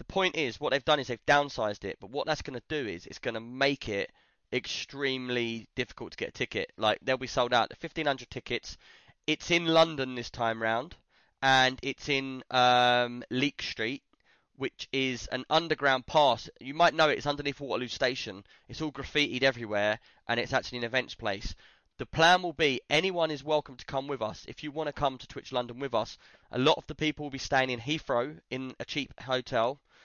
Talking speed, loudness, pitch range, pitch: 210 wpm, -29 LUFS, 125-150 Hz, 135 Hz